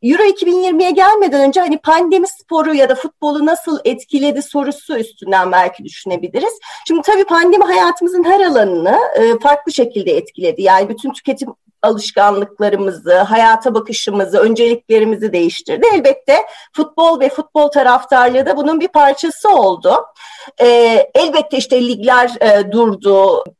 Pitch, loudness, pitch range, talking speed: 275 Hz, -12 LUFS, 225-335 Hz, 120 wpm